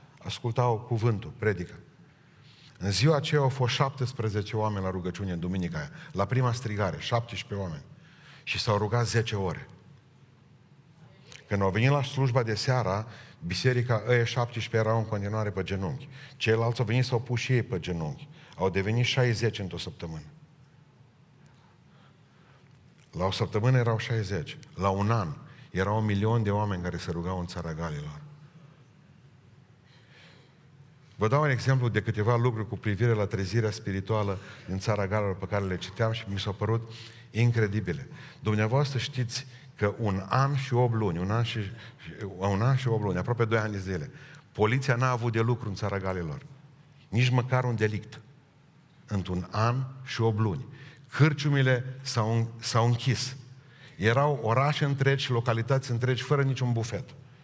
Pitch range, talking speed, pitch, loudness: 105-135 Hz, 150 wpm, 120 Hz, -28 LUFS